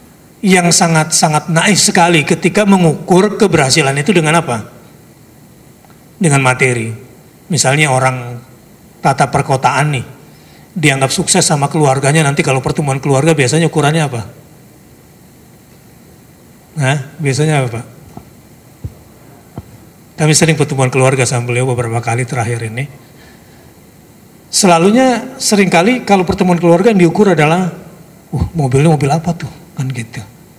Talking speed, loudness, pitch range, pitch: 115 wpm, -12 LUFS, 135-175 Hz, 155 Hz